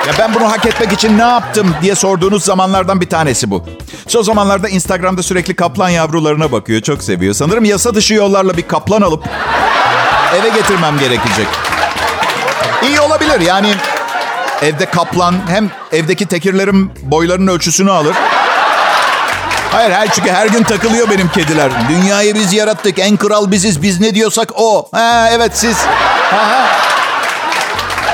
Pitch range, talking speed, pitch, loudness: 170-215 Hz, 145 wpm, 195 Hz, -11 LUFS